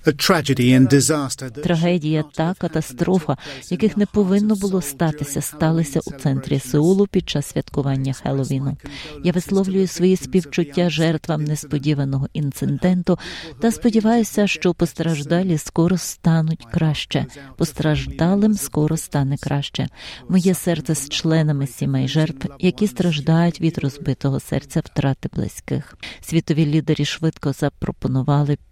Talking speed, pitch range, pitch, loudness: 105 wpm, 145-180 Hz, 160 Hz, -20 LUFS